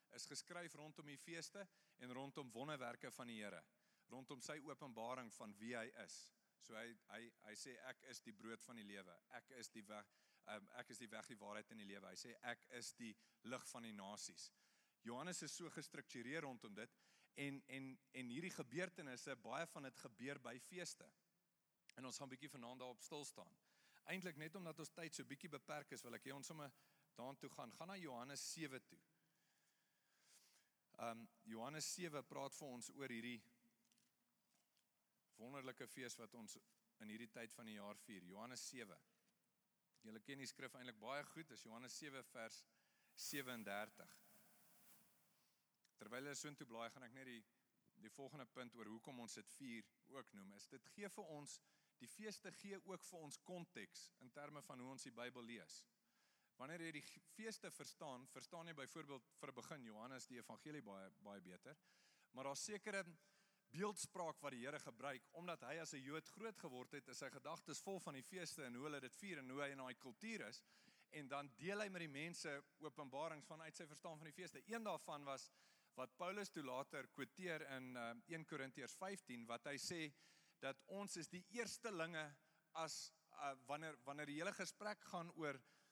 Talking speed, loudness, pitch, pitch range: 185 wpm, -54 LUFS, 140 Hz, 120-165 Hz